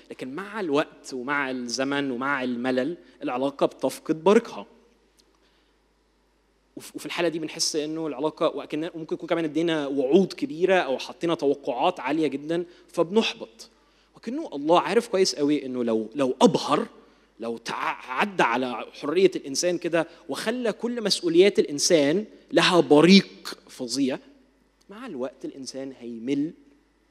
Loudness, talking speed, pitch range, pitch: -24 LUFS, 120 wpm, 135-185 Hz, 160 Hz